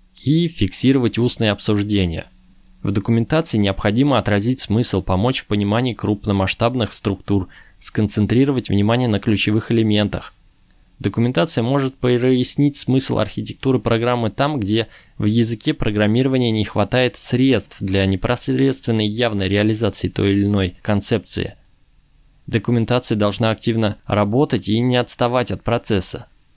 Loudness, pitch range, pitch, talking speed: -19 LUFS, 100-125 Hz, 110 Hz, 115 wpm